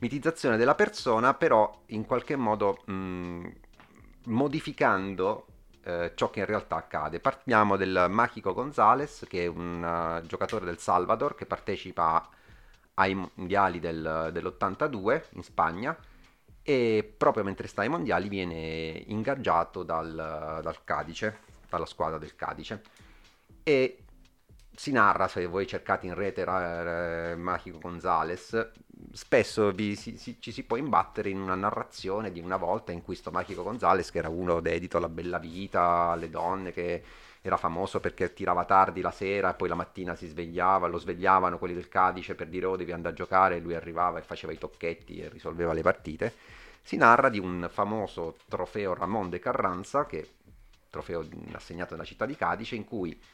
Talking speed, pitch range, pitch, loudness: 160 wpm, 85-100 Hz, 90 Hz, -29 LUFS